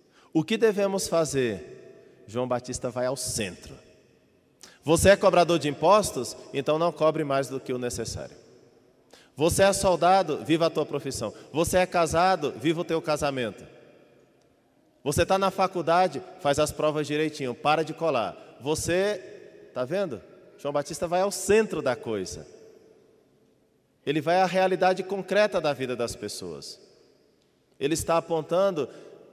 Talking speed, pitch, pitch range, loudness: 140 wpm, 165 Hz, 140-190 Hz, -26 LUFS